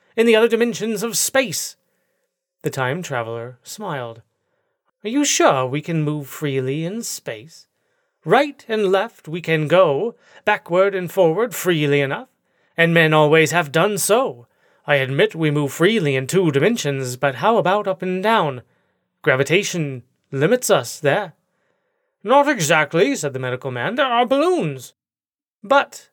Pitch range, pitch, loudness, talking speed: 145-230 Hz, 180 Hz, -19 LUFS, 145 wpm